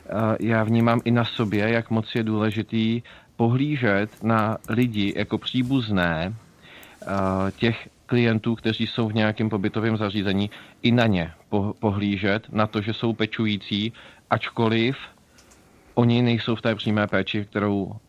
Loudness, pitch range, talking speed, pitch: -24 LUFS, 105-115 Hz, 130 wpm, 110 Hz